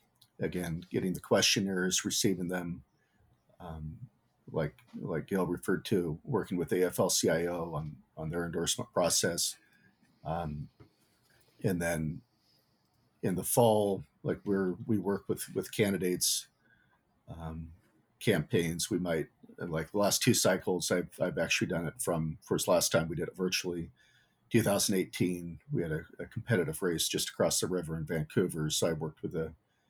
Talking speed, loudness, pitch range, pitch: 145 wpm, -32 LUFS, 80-90 Hz, 85 Hz